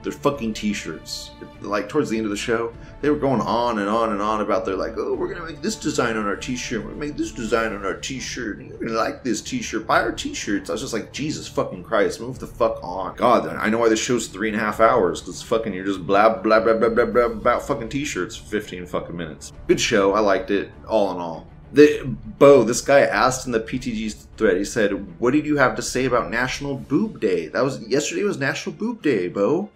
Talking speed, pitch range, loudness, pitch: 250 wpm, 105-140 Hz, -21 LUFS, 115 Hz